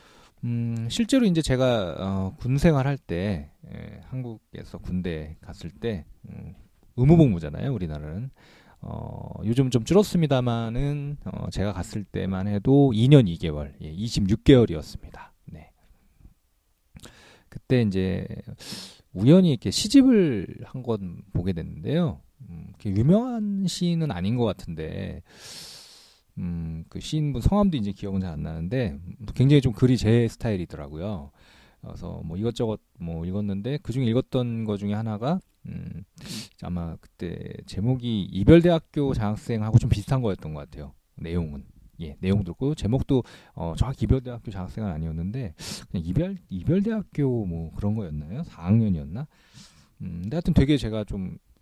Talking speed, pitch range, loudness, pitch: 295 characters per minute, 90-130 Hz, -25 LUFS, 110 Hz